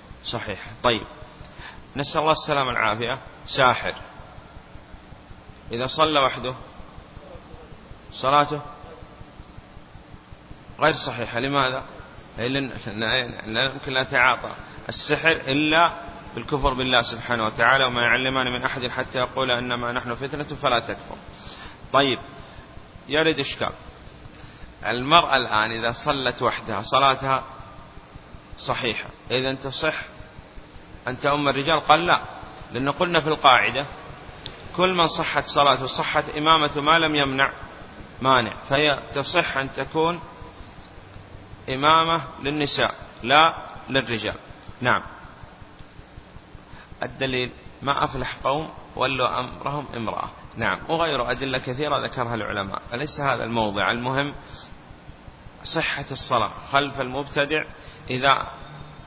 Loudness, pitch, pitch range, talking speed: -22 LUFS, 135 Hz, 120-150 Hz, 100 wpm